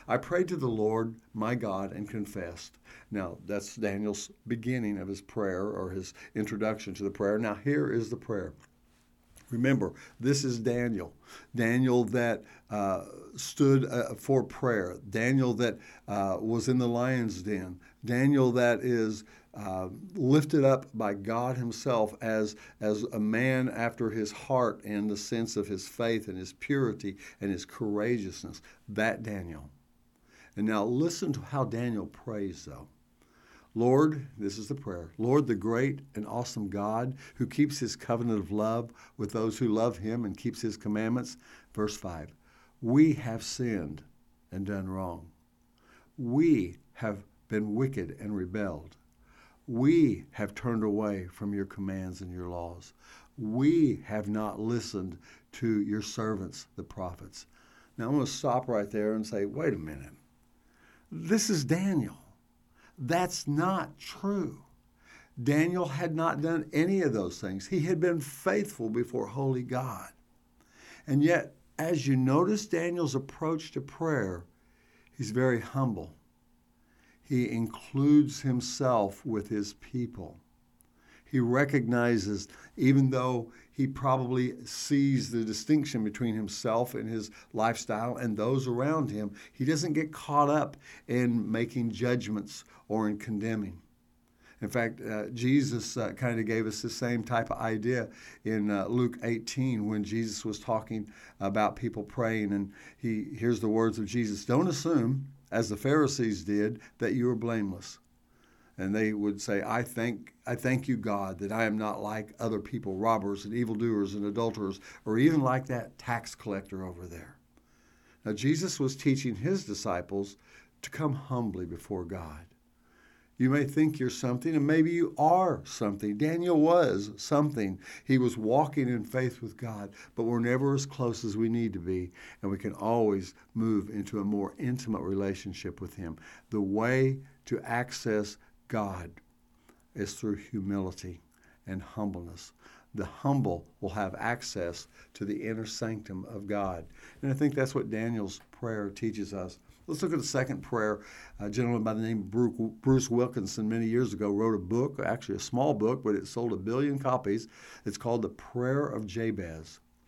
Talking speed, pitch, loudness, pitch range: 155 wpm, 115 Hz, -31 LUFS, 105-130 Hz